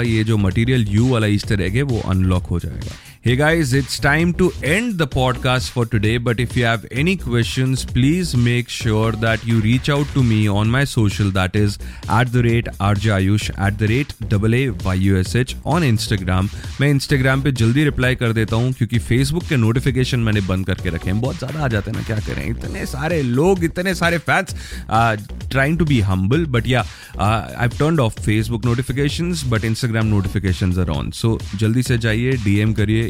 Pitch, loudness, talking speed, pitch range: 115 Hz, -18 LUFS, 200 wpm, 105-130 Hz